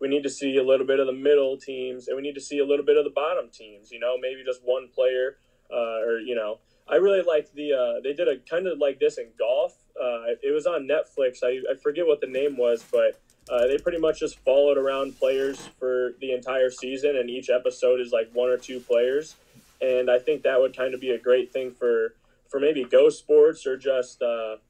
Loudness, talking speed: -24 LUFS, 245 wpm